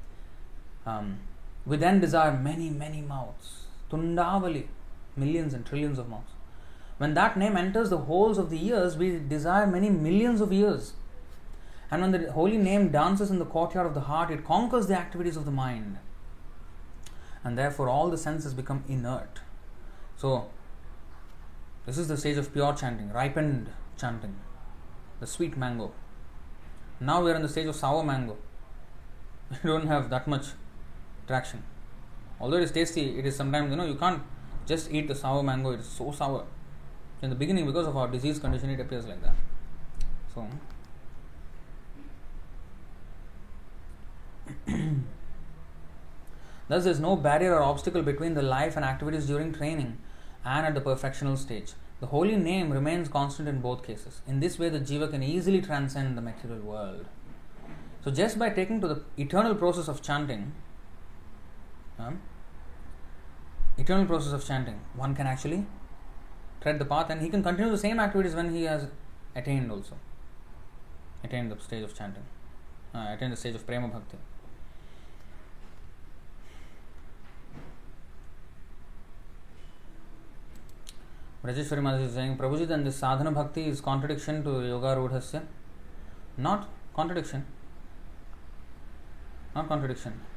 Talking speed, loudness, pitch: 140 wpm, -29 LUFS, 130 Hz